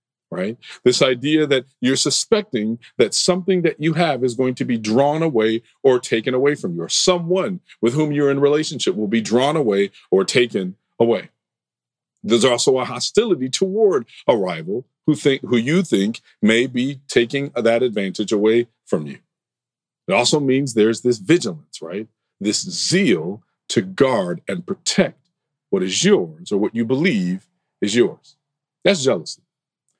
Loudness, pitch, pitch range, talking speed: -19 LUFS, 140 Hz, 120-170 Hz, 160 wpm